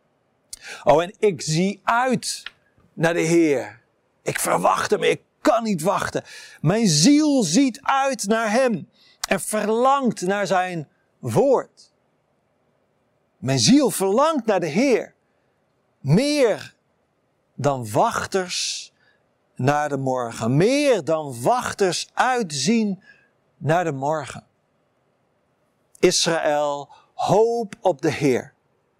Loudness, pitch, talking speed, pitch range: -21 LUFS, 195 Hz, 105 wpm, 155-235 Hz